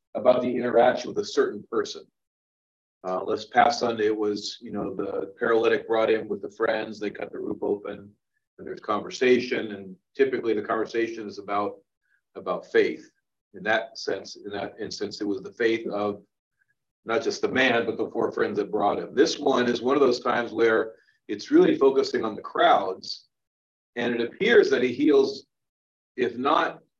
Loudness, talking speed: -25 LUFS, 180 wpm